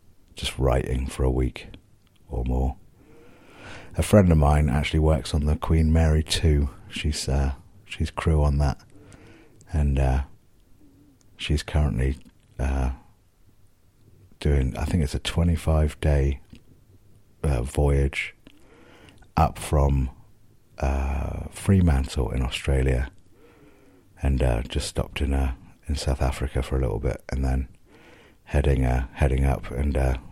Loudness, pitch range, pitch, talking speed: -25 LUFS, 65-95 Hz, 75 Hz, 130 wpm